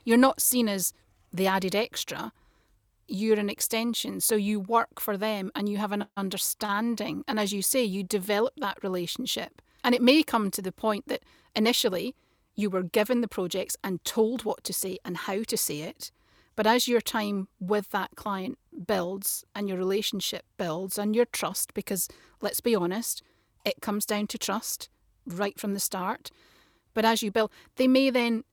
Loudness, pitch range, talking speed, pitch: -28 LUFS, 195-230 Hz, 185 wpm, 210 Hz